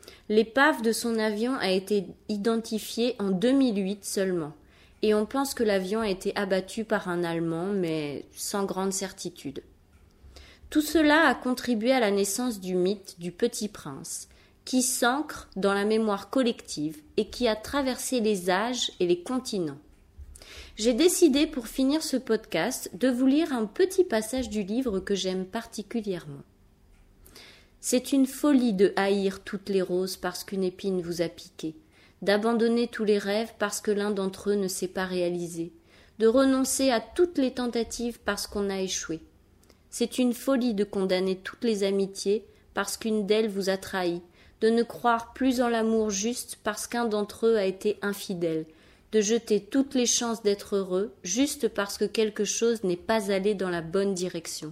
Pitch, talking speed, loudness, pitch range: 210 Hz, 170 wpm, -27 LUFS, 190-240 Hz